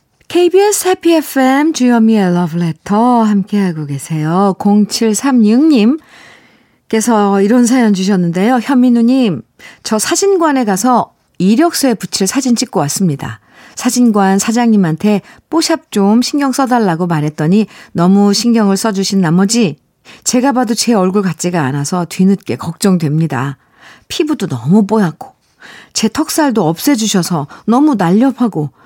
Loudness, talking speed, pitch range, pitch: -12 LUFS, 295 characters per minute, 185-250 Hz, 215 Hz